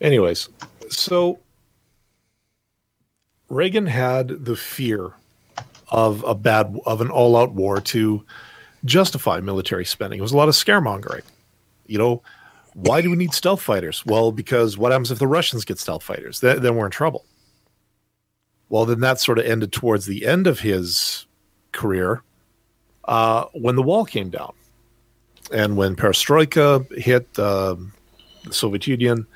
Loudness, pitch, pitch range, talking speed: -20 LUFS, 115 Hz, 105-130 Hz, 150 wpm